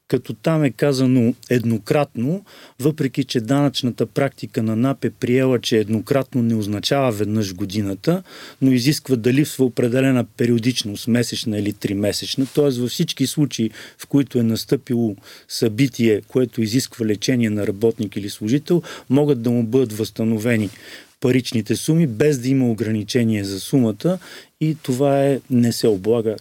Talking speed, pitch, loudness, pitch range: 145 wpm, 125 Hz, -20 LUFS, 110-140 Hz